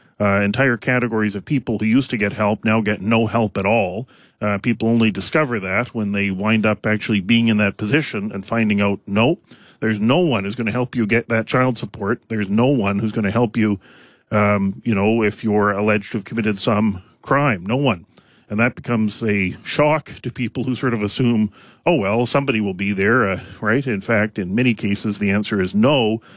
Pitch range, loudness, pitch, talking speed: 105-120 Hz, -19 LUFS, 110 Hz, 215 wpm